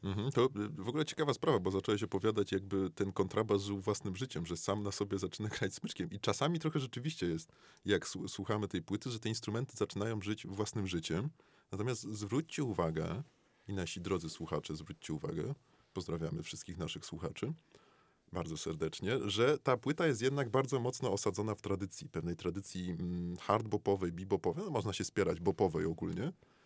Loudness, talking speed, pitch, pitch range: -37 LUFS, 165 wpm, 100 Hz, 95-120 Hz